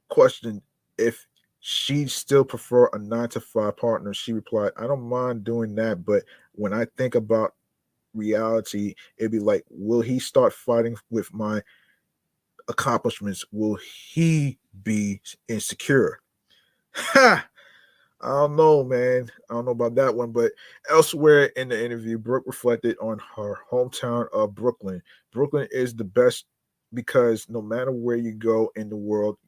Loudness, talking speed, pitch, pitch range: -23 LUFS, 150 wpm, 115 Hz, 110-125 Hz